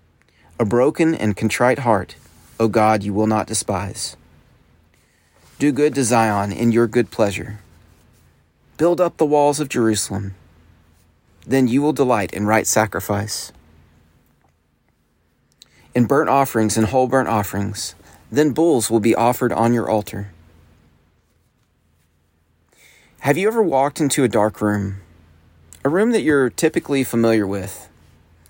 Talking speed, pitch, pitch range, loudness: 130 wpm, 110 Hz, 80-125 Hz, -18 LUFS